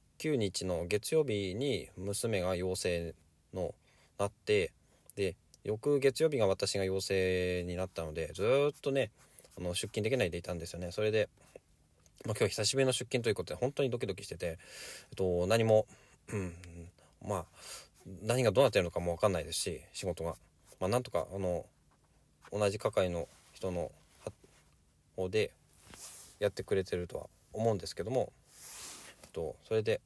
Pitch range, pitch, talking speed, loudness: 90-130 Hz, 100 Hz, 300 characters per minute, -34 LUFS